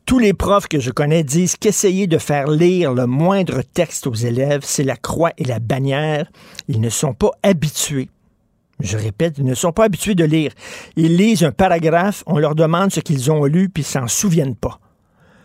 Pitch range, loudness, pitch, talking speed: 135-175 Hz, -17 LUFS, 155 Hz, 205 wpm